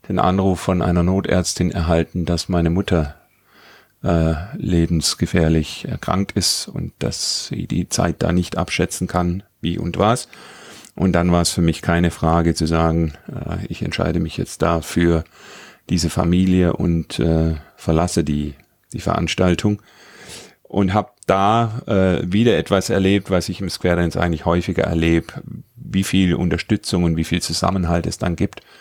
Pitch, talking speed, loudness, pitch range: 85 Hz, 155 wpm, -19 LUFS, 80-90 Hz